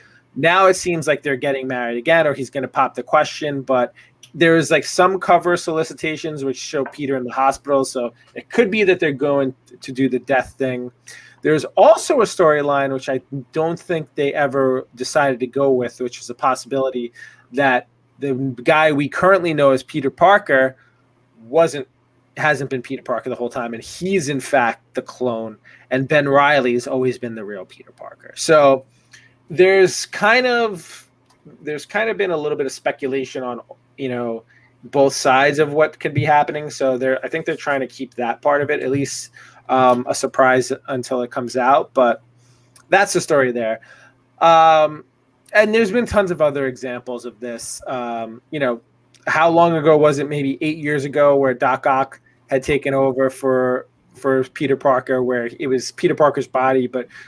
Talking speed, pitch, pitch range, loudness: 190 wpm, 135 Hz, 125-155 Hz, -18 LUFS